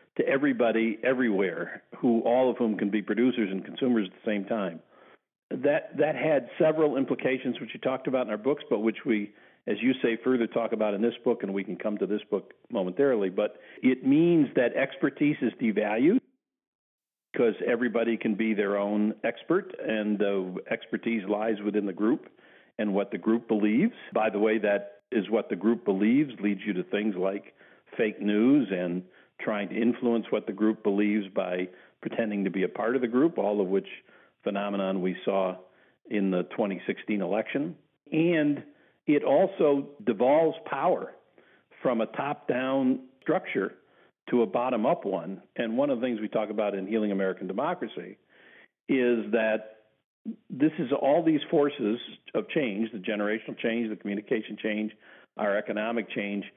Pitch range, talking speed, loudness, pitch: 105-130 Hz, 170 wpm, -28 LUFS, 110 Hz